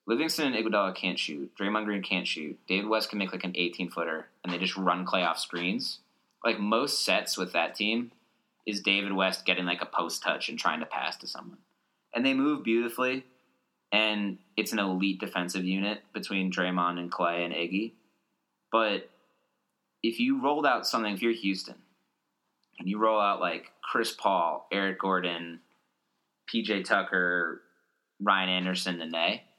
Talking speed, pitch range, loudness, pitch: 170 wpm, 90-110 Hz, -29 LUFS, 95 Hz